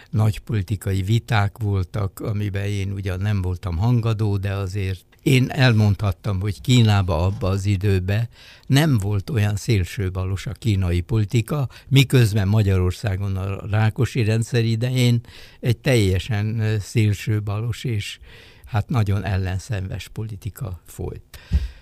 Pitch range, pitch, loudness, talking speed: 95-115 Hz, 105 Hz, -22 LUFS, 115 wpm